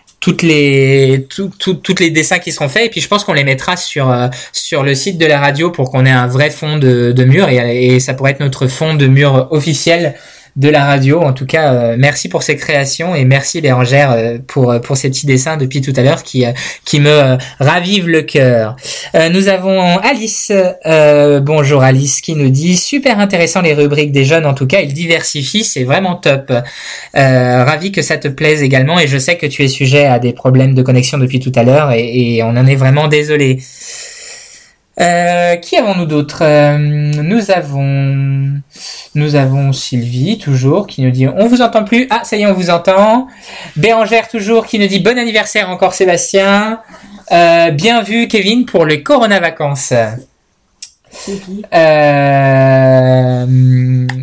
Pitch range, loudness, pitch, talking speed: 135-180 Hz, -10 LUFS, 150 Hz, 190 wpm